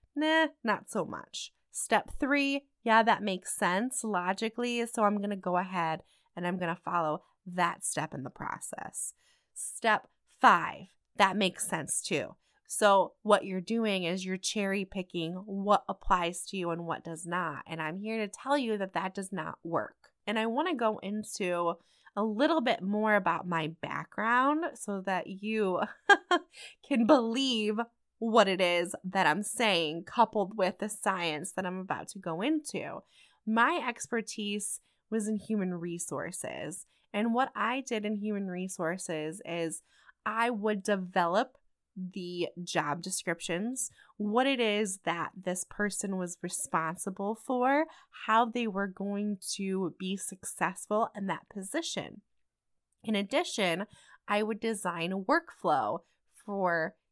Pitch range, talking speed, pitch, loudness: 180-230 Hz, 145 wpm, 200 Hz, -31 LUFS